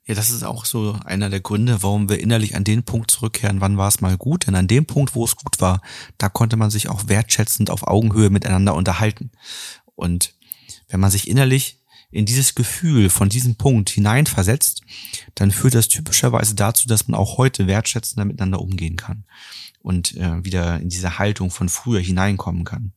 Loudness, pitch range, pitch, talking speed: -18 LUFS, 95-115 Hz, 105 Hz, 190 wpm